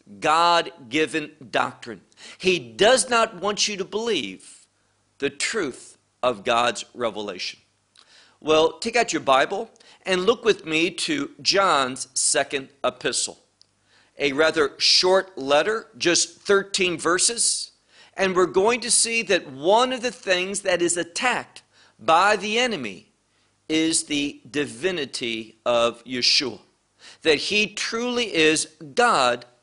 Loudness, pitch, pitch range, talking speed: -22 LUFS, 170 Hz, 135-205 Hz, 125 wpm